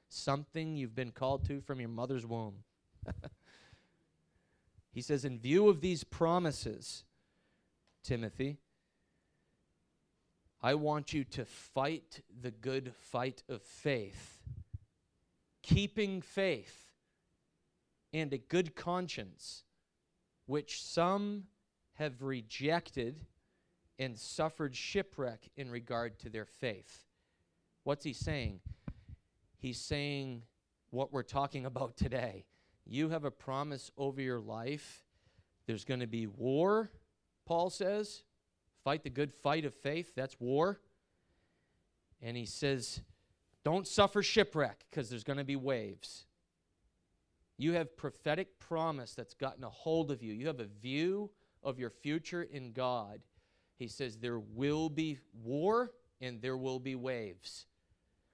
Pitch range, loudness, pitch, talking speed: 115-150 Hz, -38 LUFS, 130 Hz, 120 wpm